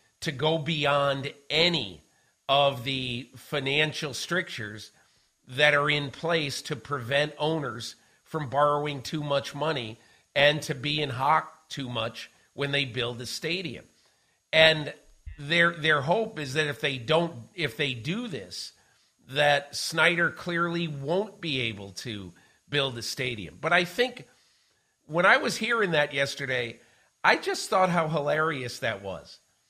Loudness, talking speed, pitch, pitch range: -26 LUFS, 145 wpm, 145 Hz, 130-160 Hz